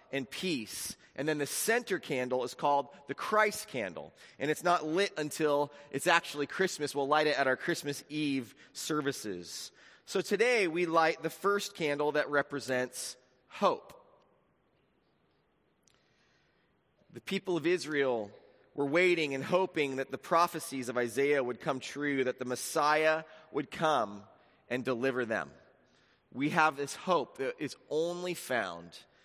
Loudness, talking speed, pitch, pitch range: -32 LUFS, 145 wpm, 145 Hz, 135-170 Hz